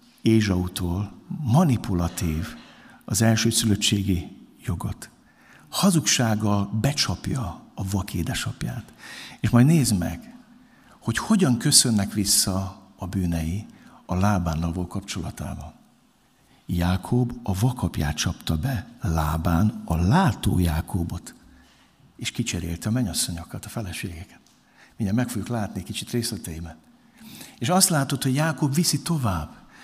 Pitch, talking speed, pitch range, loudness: 105 Hz, 105 wpm, 90-125 Hz, -24 LUFS